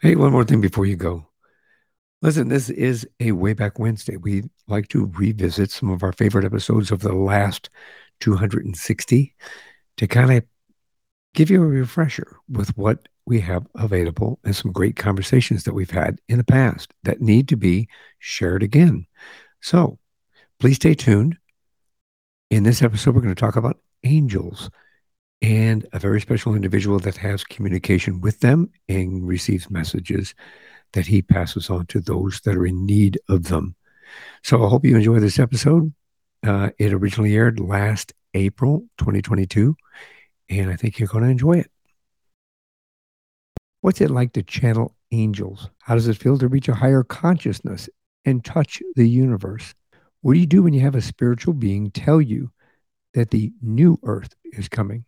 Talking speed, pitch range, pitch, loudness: 165 wpm, 100-130 Hz, 110 Hz, -19 LUFS